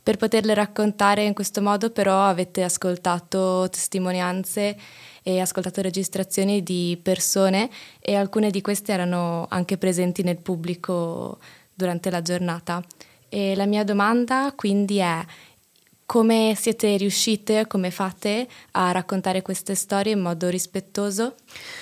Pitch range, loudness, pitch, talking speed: 180-205 Hz, -23 LUFS, 195 Hz, 125 wpm